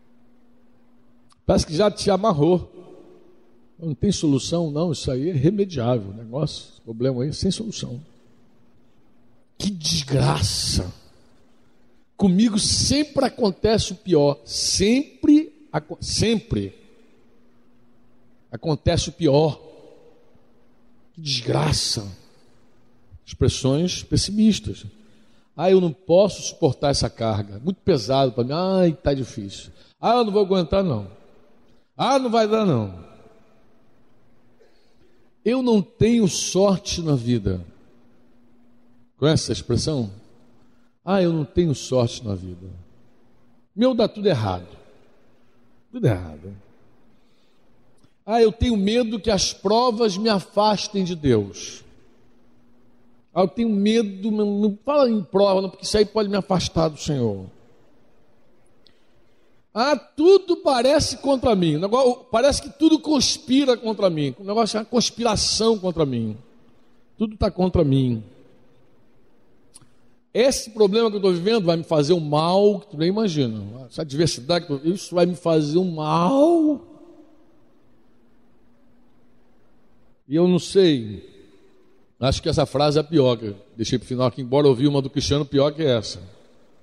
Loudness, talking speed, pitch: -21 LUFS, 130 wpm, 160 Hz